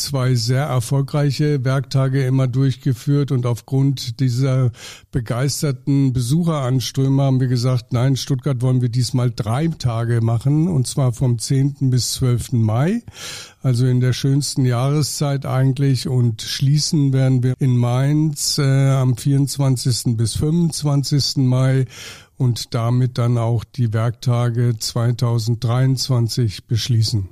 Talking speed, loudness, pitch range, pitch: 120 wpm, -18 LUFS, 120-140 Hz, 130 Hz